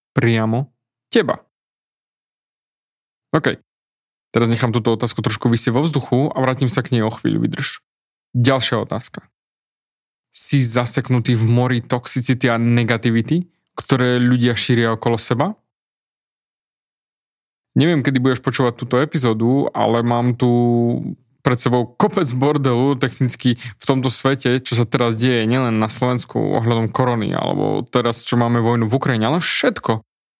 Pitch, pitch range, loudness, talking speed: 125 Hz, 120-135 Hz, -18 LUFS, 135 wpm